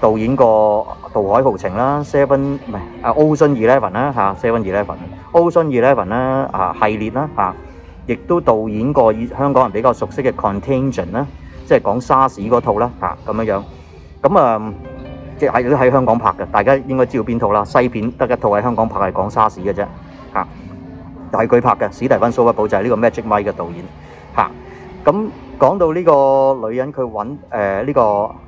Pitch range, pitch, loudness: 100-135 Hz, 115 Hz, -16 LUFS